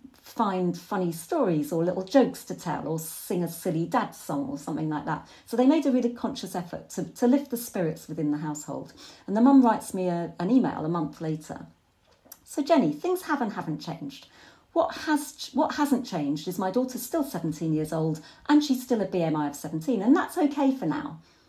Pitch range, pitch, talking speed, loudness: 160-270 Hz, 195 Hz, 210 wpm, -27 LUFS